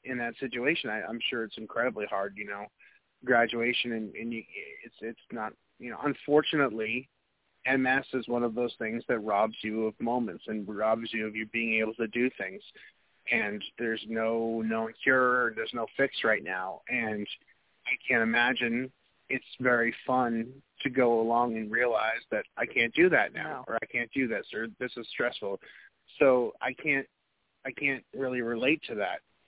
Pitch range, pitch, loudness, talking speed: 110-130 Hz, 120 Hz, -29 LUFS, 180 wpm